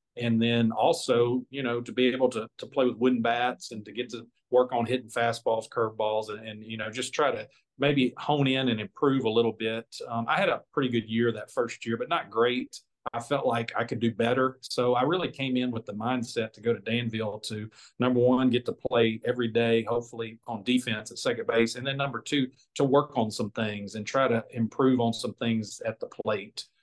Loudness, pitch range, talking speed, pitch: -28 LUFS, 115-125 Hz, 230 wpm, 120 Hz